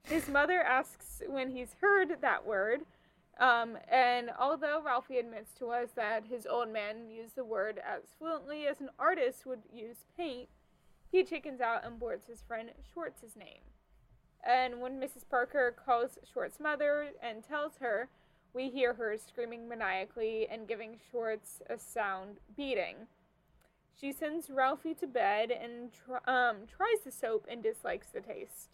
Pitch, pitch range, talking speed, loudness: 250 Hz, 230-300 Hz, 155 wpm, -35 LUFS